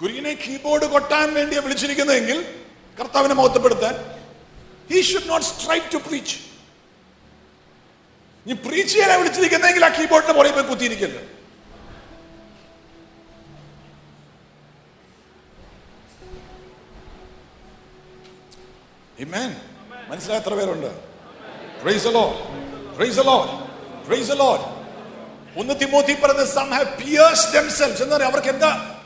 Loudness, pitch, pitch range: -18 LUFS, 280 Hz, 260-310 Hz